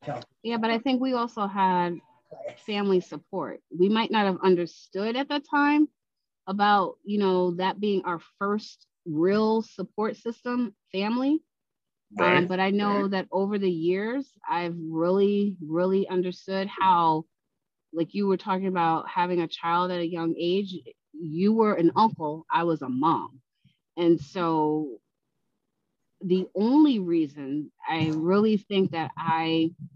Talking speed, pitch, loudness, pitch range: 140 wpm, 185 Hz, -26 LUFS, 170-210 Hz